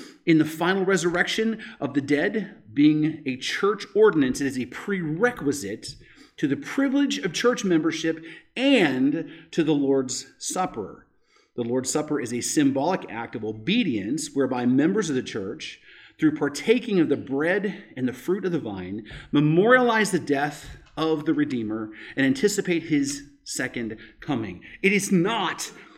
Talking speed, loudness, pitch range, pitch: 150 wpm, -24 LUFS, 140-210 Hz, 160 Hz